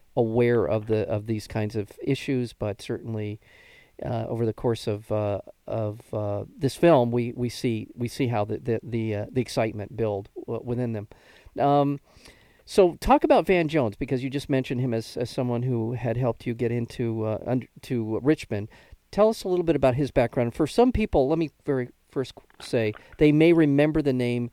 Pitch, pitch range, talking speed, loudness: 120 Hz, 110-140 Hz, 195 wpm, -25 LUFS